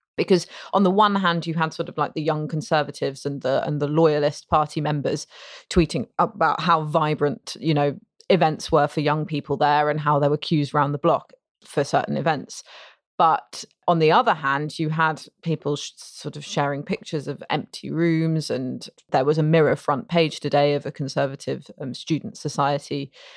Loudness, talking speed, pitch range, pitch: -23 LUFS, 185 wpm, 145-160 Hz, 150 Hz